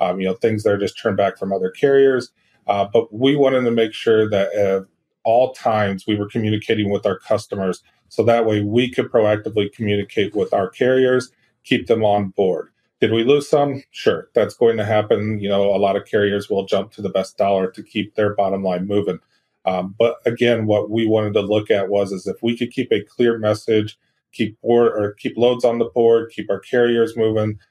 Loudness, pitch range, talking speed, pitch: -19 LUFS, 100-120 Hz, 215 wpm, 110 Hz